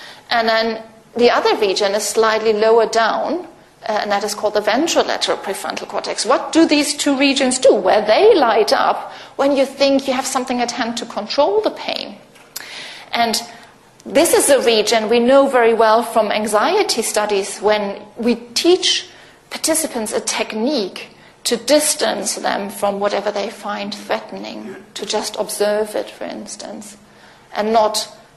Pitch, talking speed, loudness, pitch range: 230 Hz, 160 wpm, -16 LUFS, 215-275 Hz